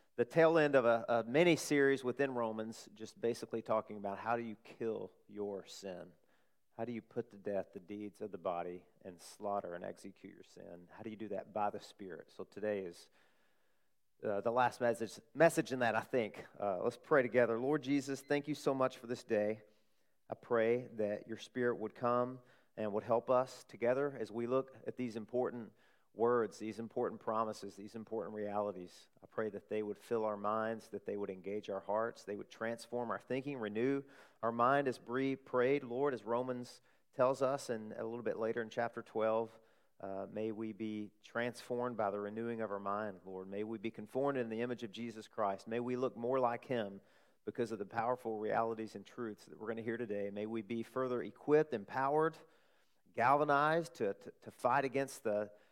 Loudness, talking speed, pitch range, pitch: -38 LUFS, 200 wpm, 105-125 Hz, 115 Hz